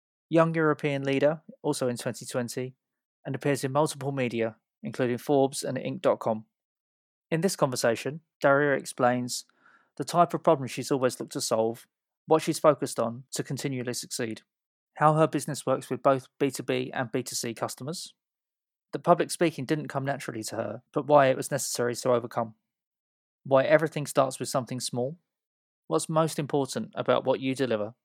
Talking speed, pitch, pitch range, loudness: 160 wpm, 135 Hz, 125-150 Hz, -28 LUFS